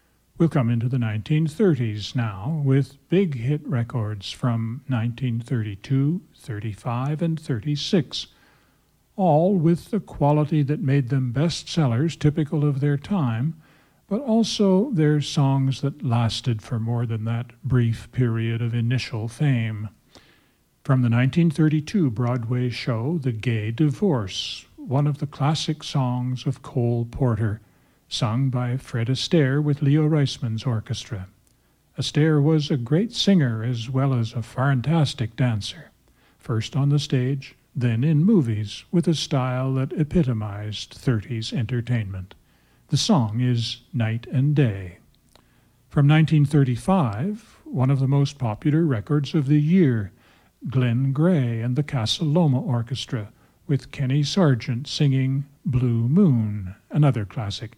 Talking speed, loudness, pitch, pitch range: 130 wpm, -23 LUFS, 130 Hz, 120-150 Hz